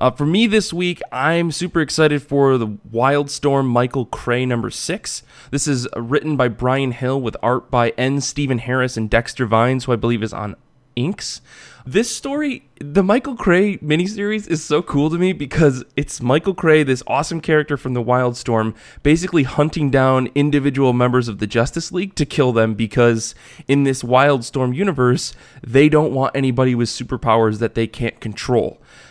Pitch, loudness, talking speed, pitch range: 135 Hz, -18 LUFS, 175 wpm, 120-155 Hz